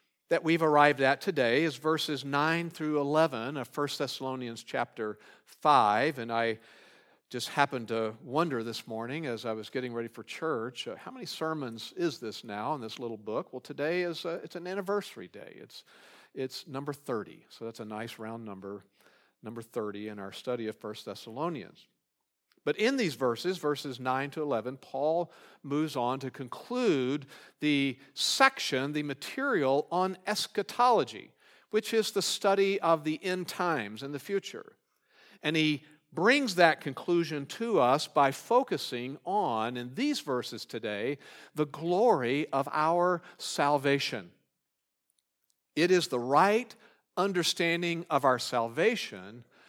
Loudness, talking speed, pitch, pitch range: -30 LUFS, 150 wpm, 145 Hz, 125-170 Hz